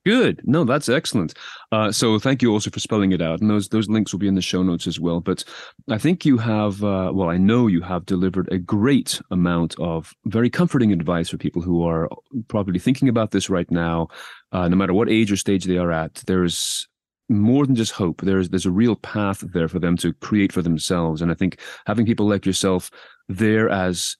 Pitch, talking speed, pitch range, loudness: 95 Hz, 225 wpm, 90-110 Hz, -20 LUFS